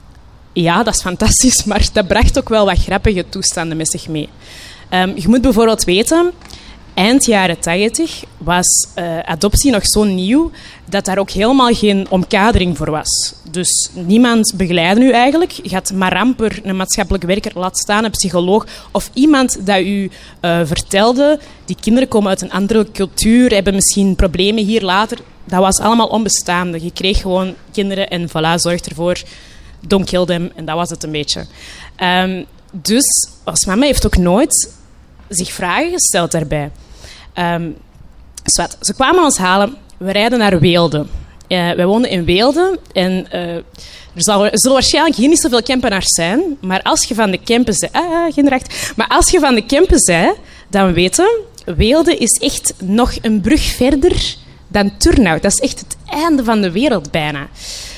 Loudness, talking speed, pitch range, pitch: -13 LUFS, 170 wpm, 175-240 Hz, 195 Hz